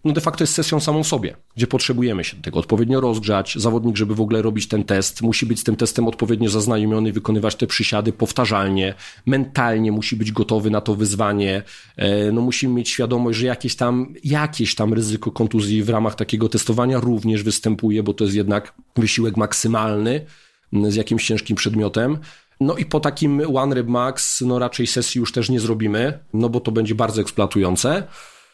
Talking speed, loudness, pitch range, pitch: 180 wpm, -20 LUFS, 110-125 Hz, 115 Hz